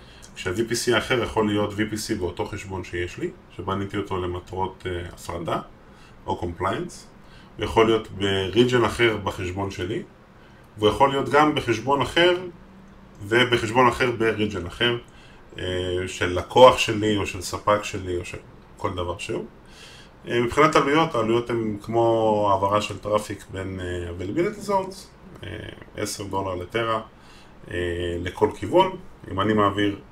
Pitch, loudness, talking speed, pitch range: 105 Hz, -23 LUFS, 135 wpm, 95-120 Hz